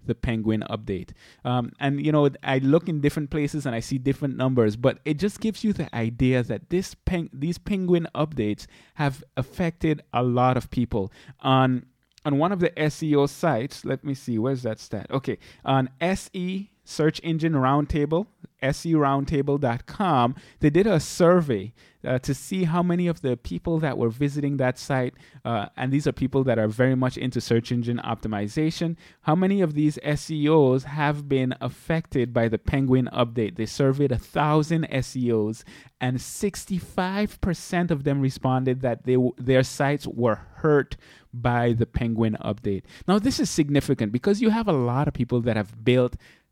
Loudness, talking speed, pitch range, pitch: -24 LUFS, 170 wpm, 120-160 Hz, 135 Hz